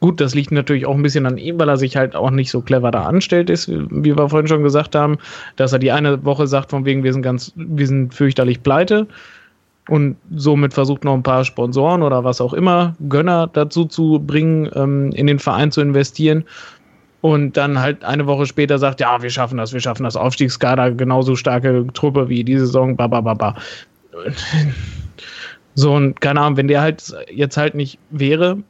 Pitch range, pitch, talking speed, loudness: 130-150 Hz, 140 Hz, 200 wpm, -16 LUFS